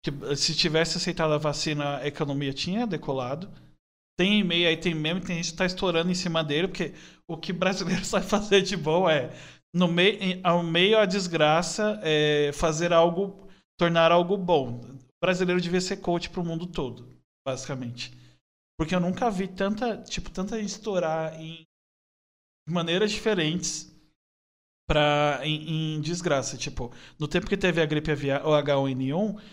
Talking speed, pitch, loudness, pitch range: 165 wpm, 165 Hz, -26 LUFS, 150-185 Hz